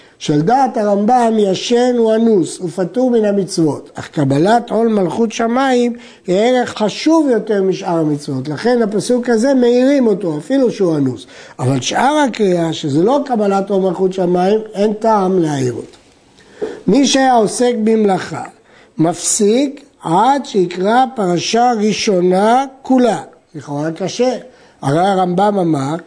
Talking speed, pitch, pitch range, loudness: 130 wpm, 210 Hz, 180-245 Hz, -14 LUFS